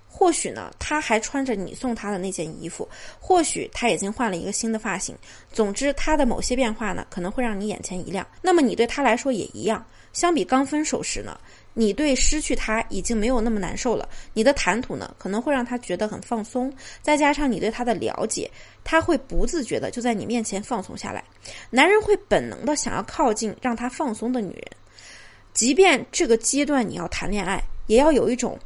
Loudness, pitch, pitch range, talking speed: -23 LUFS, 240 Hz, 215-285 Hz, 310 characters per minute